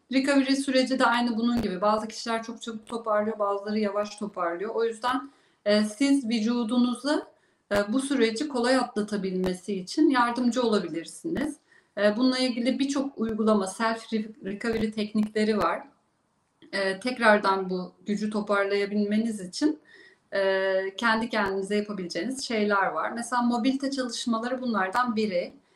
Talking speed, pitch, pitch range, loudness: 125 wpm, 225 Hz, 205-250 Hz, -27 LUFS